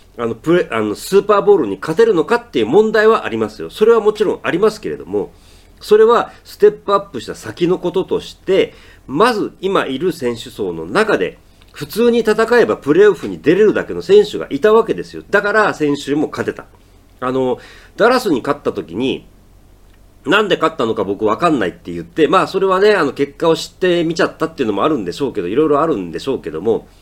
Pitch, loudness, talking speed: 185 Hz, -15 LUFS, 425 characters per minute